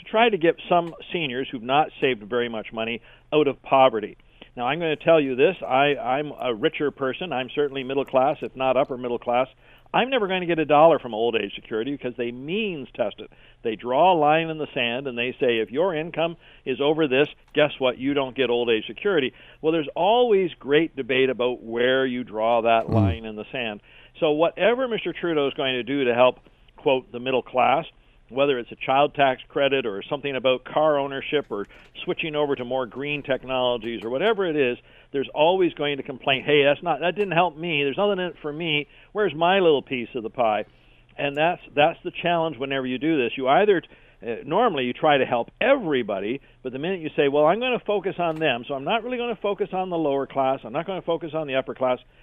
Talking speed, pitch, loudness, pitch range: 230 wpm, 140 Hz, -23 LUFS, 130-165 Hz